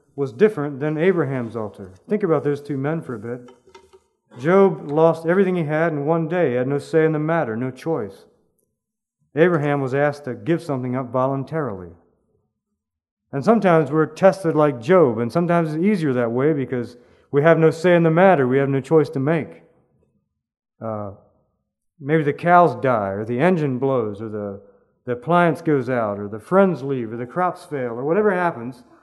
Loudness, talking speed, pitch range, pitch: -20 LUFS, 185 wpm, 125-165 Hz, 145 Hz